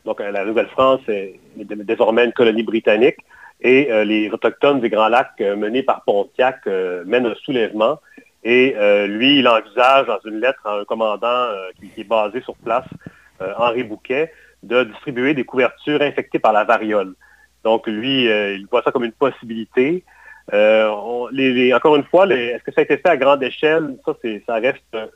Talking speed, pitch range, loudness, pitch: 195 wpm, 110-135 Hz, -17 LUFS, 120 Hz